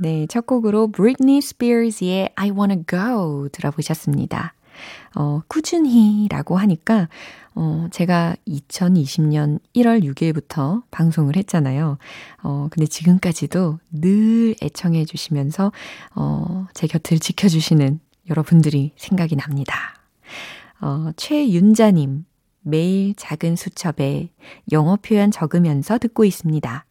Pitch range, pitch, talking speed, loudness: 155-205 Hz, 170 Hz, 255 characters per minute, -19 LUFS